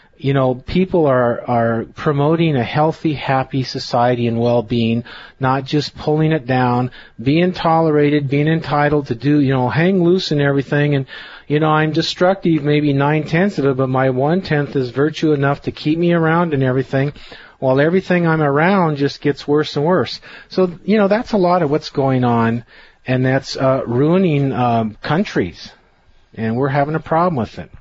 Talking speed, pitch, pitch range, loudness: 180 wpm, 145 Hz, 130-160 Hz, -16 LUFS